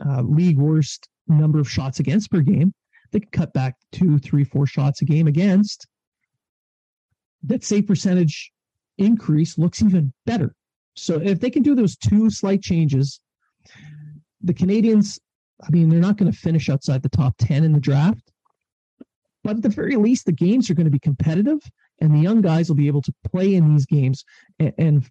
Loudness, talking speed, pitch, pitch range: -19 LUFS, 185 wpm, 160 Hz, 145-195 Hz